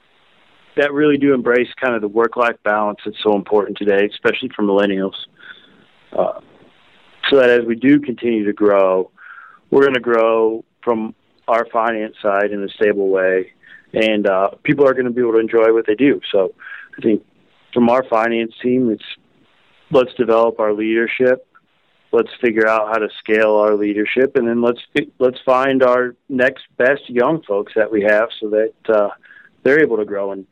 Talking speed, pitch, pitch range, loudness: 180 wpm, 115 Hz, 105-125 Hz, -16 LUFS